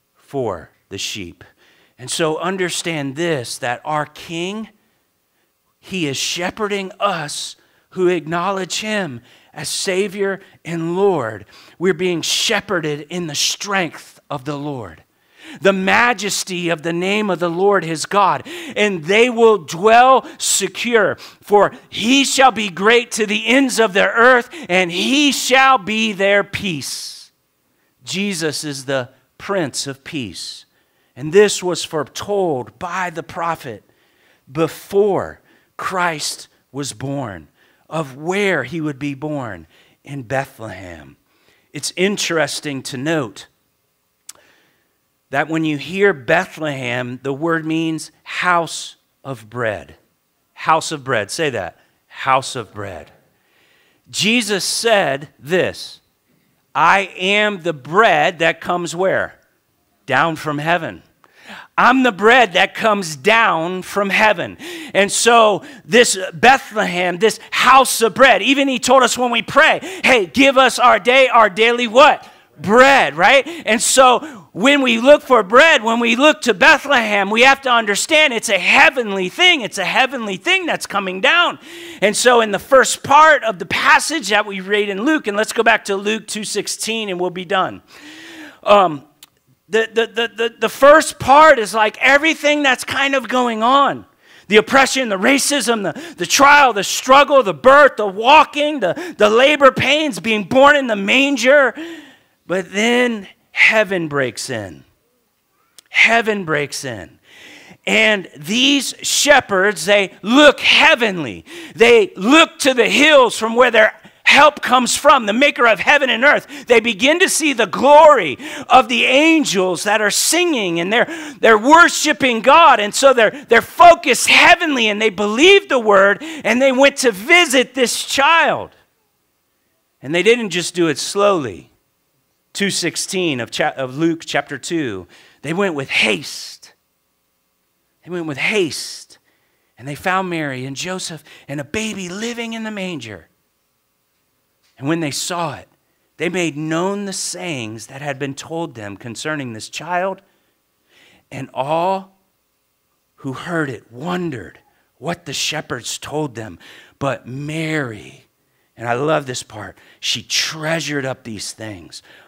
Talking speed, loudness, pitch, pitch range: 145 wpm, -14 LUFS, 195 Hz, 155-245 Hz